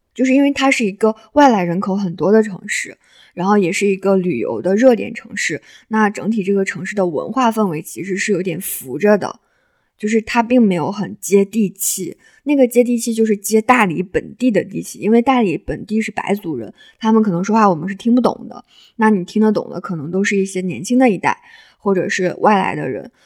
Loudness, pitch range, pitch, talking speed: -16 LUFS, 190-240 Hz, 210 Hz, 315 characters per minute